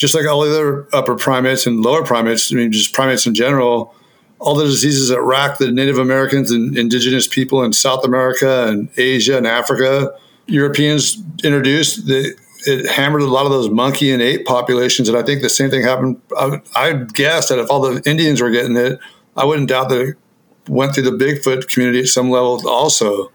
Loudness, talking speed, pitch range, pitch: -14 LUFS, 205 wpm, 125-140 Hz, 130 Hz